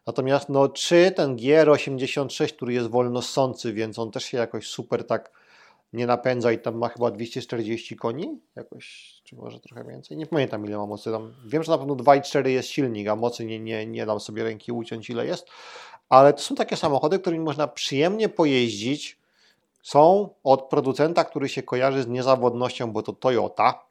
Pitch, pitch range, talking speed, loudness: 130 Hz, 115-145 Hz, 180 wpm, -23 LUFS